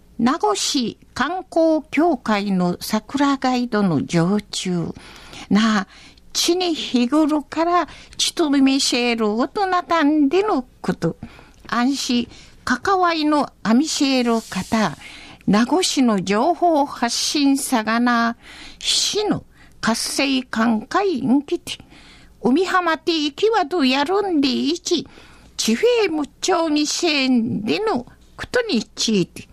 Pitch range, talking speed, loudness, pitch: 225-335 Hz, 190 characters per minute, -19 LUFS, 275 Hz